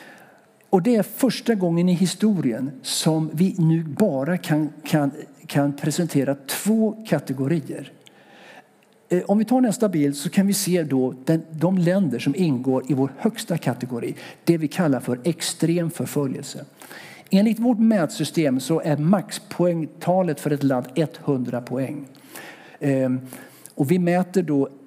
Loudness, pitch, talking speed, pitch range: -22 LUFS, 165 Hz, 140 wpm, 140-190 Hz